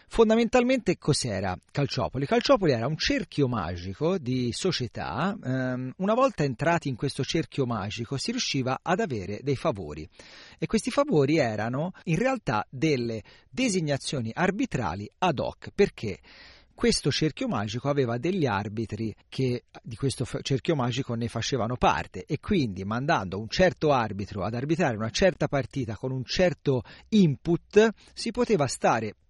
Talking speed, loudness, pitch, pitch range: 135 wpm, -27 LUFS, 140 Hz, 120-180 Hz